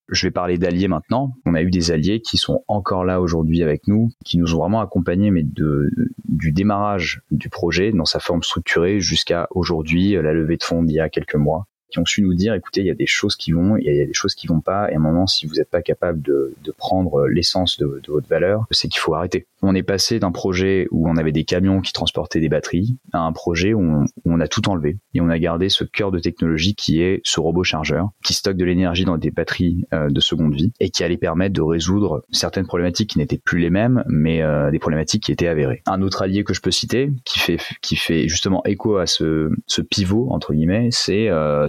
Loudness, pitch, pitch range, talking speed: -19 LUFS, 90 Hz, 80-100 Hz, 250 wpm